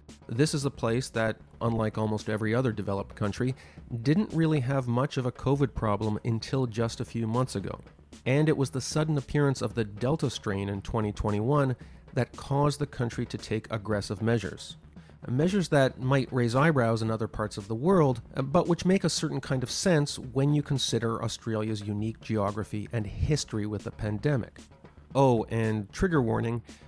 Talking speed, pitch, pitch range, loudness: 175 wpm, 120 Hz, 110-140 Hz, -29 LUFS